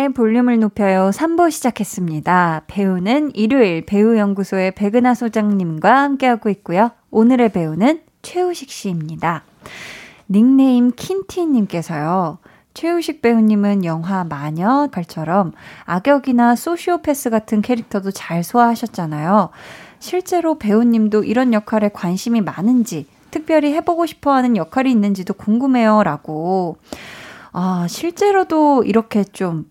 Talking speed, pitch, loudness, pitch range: 300 characters per minute, 220 Hz, -16 LUFS, 185-265 Hz